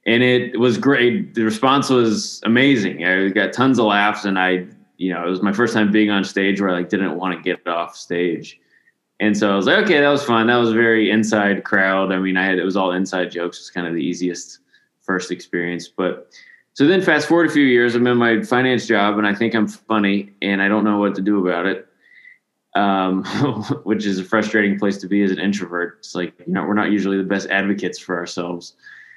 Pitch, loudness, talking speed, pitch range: 100 Hz, -18 LUFS, 240 wpm, 95-115 Hz